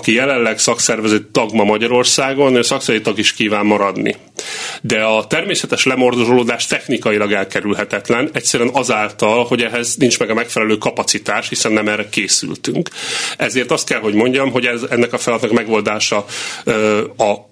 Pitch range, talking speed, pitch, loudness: 105-125 Hz, 145 wpm, 115 Hz, -15 LUFS